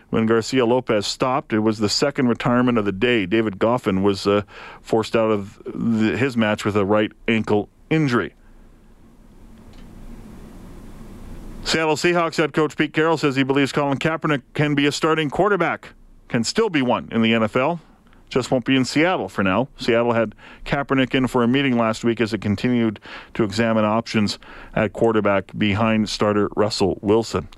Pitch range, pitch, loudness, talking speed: 110-140 Hz, 115 Hz, -20 LUFS, 170 wpm